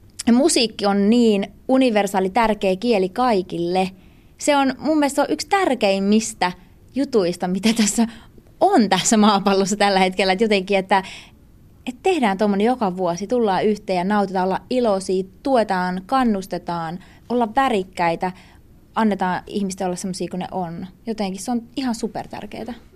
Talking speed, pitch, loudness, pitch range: 140 wpm, 205 Hz, -20 LUFS, 190-235 Hz